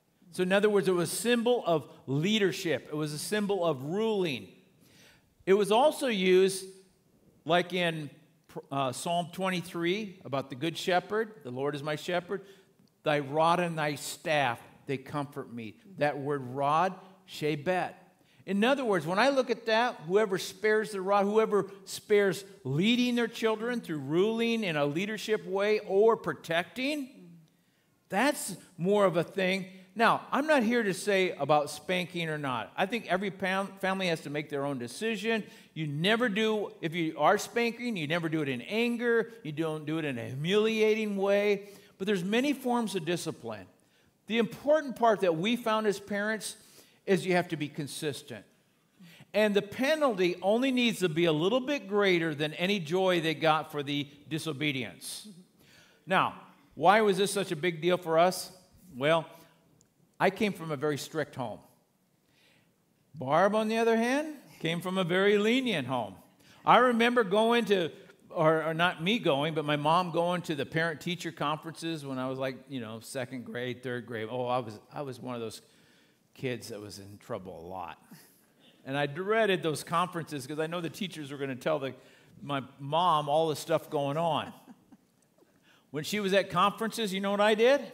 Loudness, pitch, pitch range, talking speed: -29 LUFS, 180 Hz, 150-210 Hz, 180 wpm